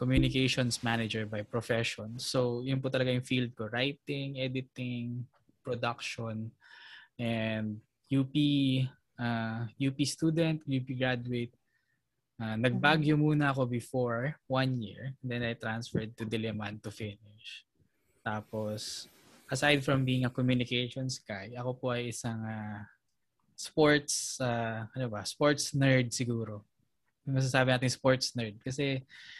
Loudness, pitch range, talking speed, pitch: -32 LUFS, 115-130 Hz, 120 wpm, 125 Hz